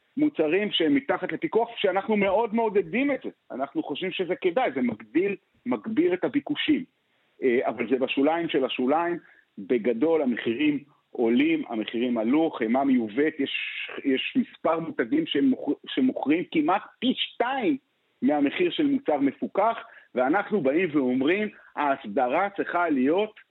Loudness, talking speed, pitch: -26 LUFS, 125 wpm, 210 Hz